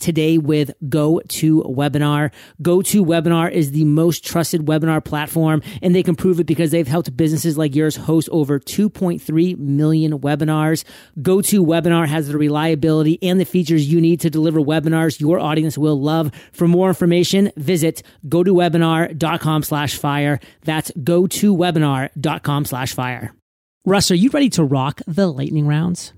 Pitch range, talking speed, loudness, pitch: 150-175 Hz, 140 wpm, -17 LUFS, 160 Hz